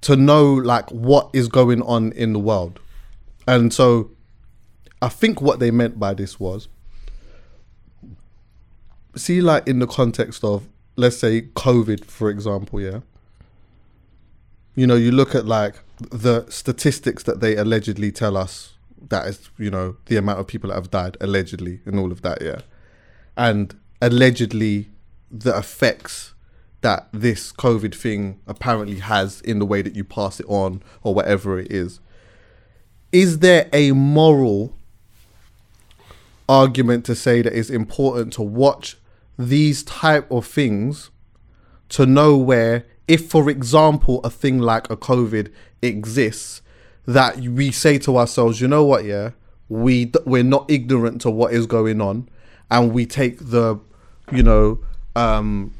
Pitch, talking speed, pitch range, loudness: 110 Hz, 150 wpm, 100-125 Hz, -18 LUFS